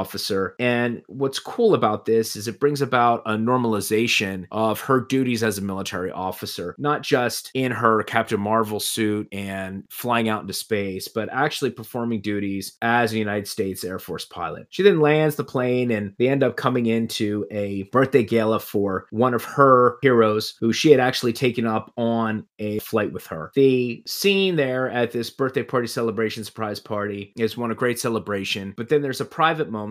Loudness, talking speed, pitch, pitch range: -22 LUFS, 185 wpm, 115 Hz, 105-125 Hz